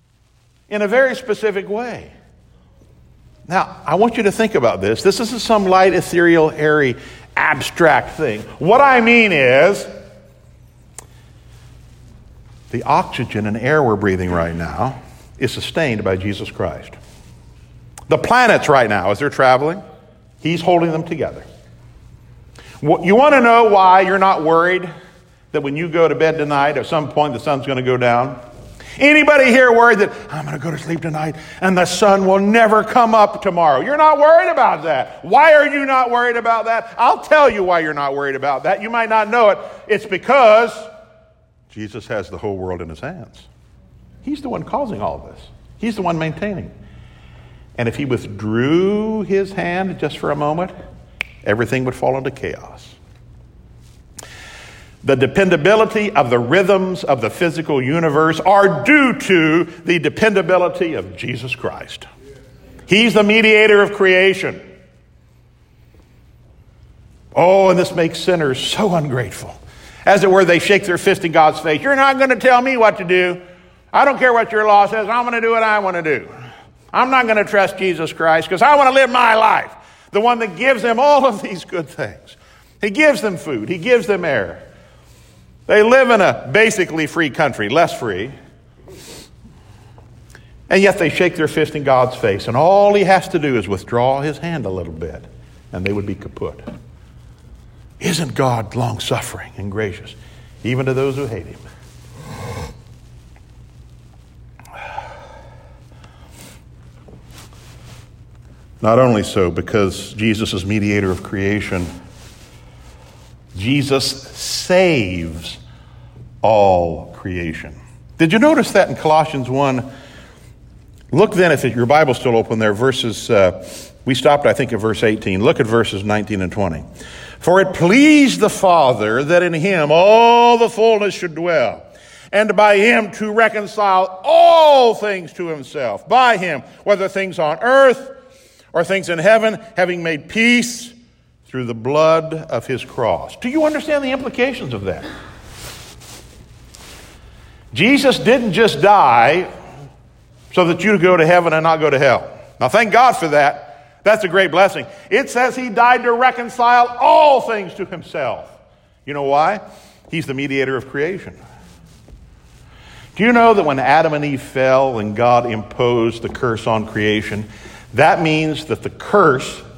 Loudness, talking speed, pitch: -15 LUFS, 160 wpm, 165 Hz